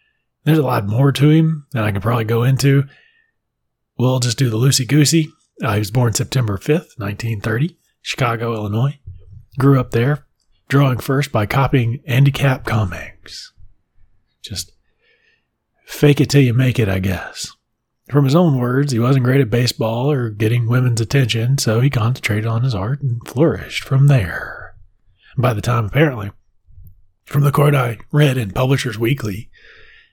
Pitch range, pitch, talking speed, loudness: 110-140 Hz, 125 Hz, 160 wpm, -17 LUFS